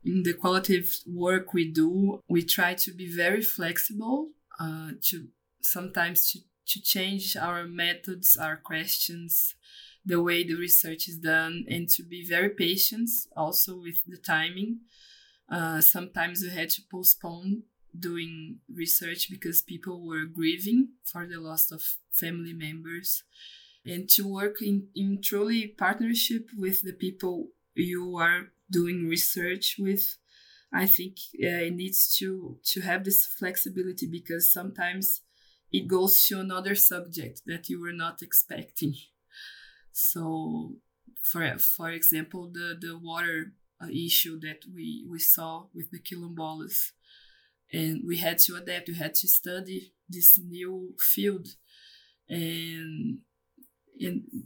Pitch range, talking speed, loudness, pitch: 170-195 Hz, 135 wpm, -25 LUFS, 175 Hz